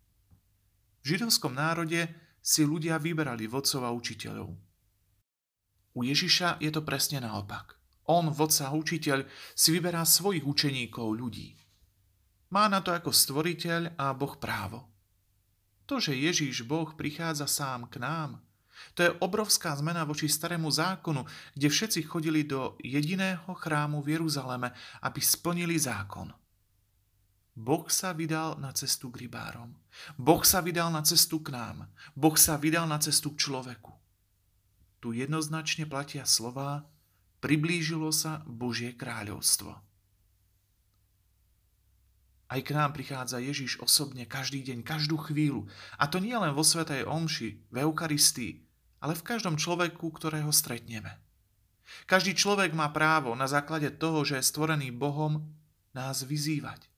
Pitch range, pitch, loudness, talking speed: 110-160 Hz, 140 Hz, -29 LUFS, 130 wpm